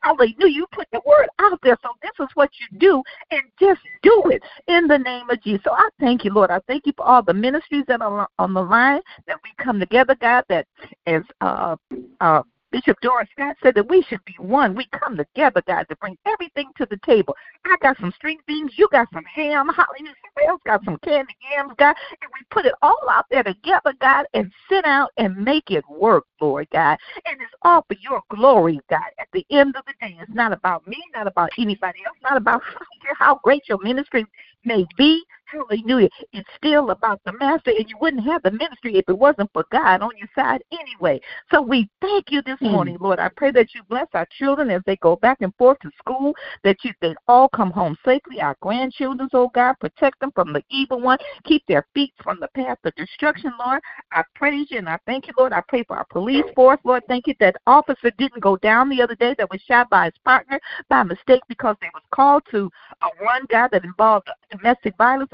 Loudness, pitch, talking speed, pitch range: -19 LUFS, 255 Hz, 225 wpm, 215-290 Hz